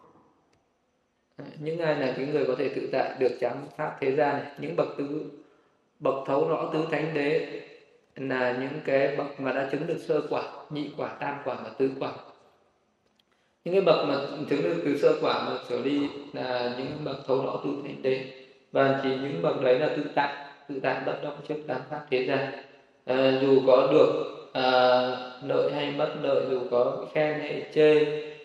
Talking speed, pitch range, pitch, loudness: 195 wpm, 130-150 Hz, 140 Hz, -27 LUFS